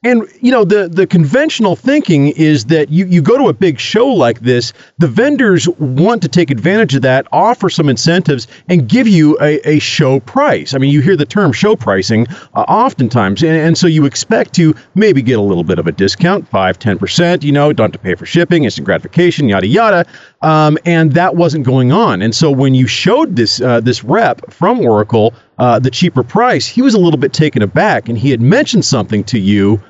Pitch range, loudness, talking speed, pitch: 125-180 Hz, -11 LUFS, 220 wpm, 155 Hz